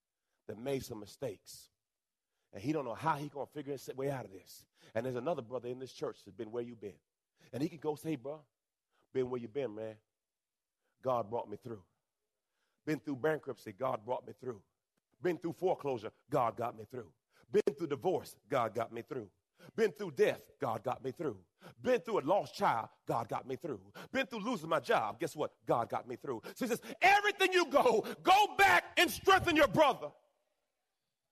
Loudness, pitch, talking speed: -34 LUFS, 150 Hz, 200 wpm